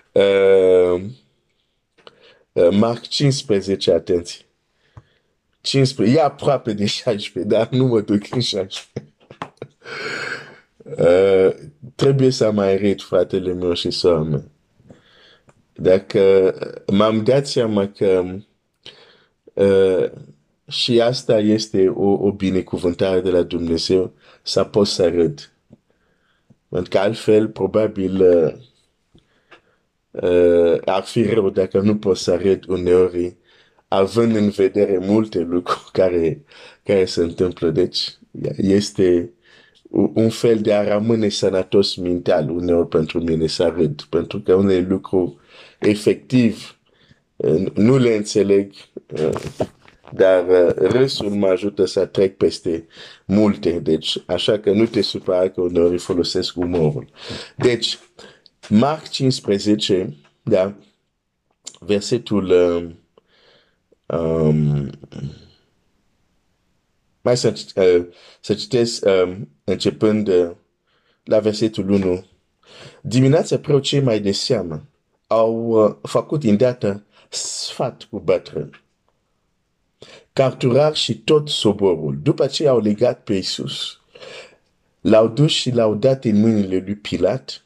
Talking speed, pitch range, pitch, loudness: 105 wpm, 90-115 Hz, 100 Hz, -18 LUFS